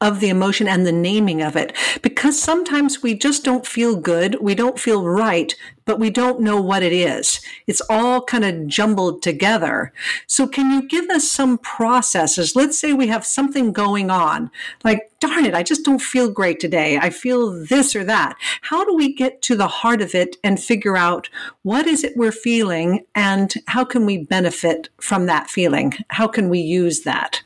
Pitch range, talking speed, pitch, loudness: 185-255 Hz, 195 wpm, 220 Hz, -18 LUFS